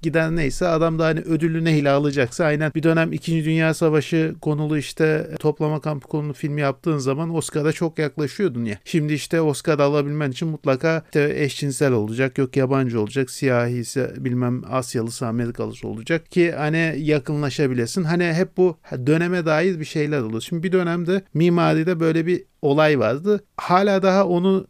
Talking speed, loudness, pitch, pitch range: 160 wpm, -21 LUFS, 155 Hz, 140-165 Hz